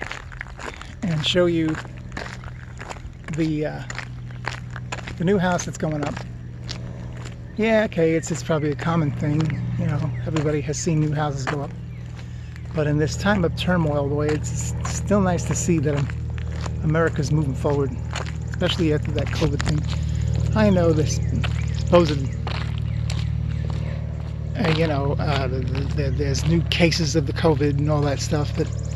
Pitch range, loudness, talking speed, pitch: 120-155 Hz, -23 LUFS, 150 wpm, 145 Hz